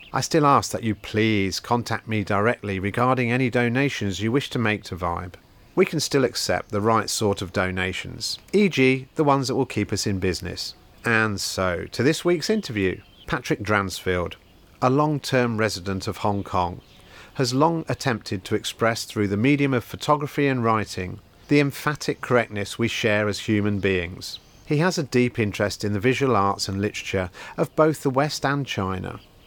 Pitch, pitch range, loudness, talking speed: 110 Hz, 100-135 Hz, -23 LUFS, 180 wpm